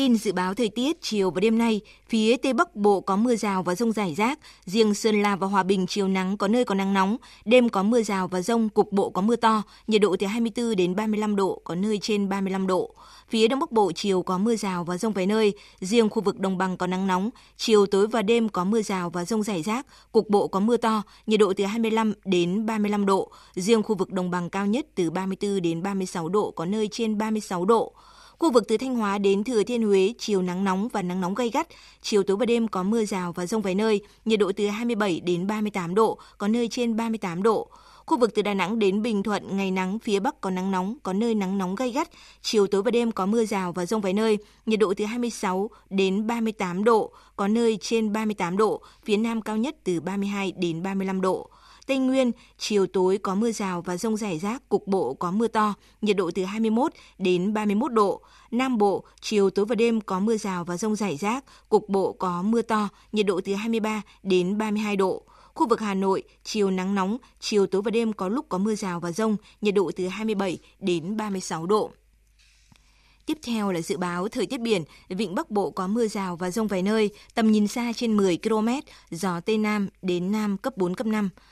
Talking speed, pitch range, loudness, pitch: 230 wpm, 190-225 Hz, -25 LUFS, 210 Hz